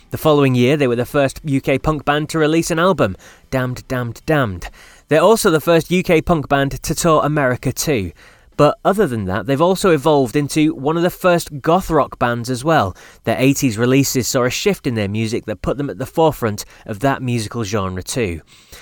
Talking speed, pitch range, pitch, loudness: 205 wpm, 120-155 Hz, 140 Hz, -17 LUFS